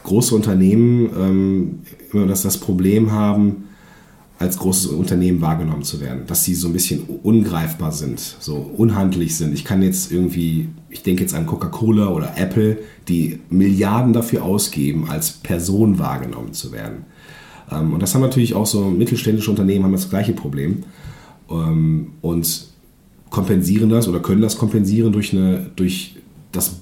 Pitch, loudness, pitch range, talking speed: 95 Hz, -18 LUFS, 85-110 Hz, 145 wpm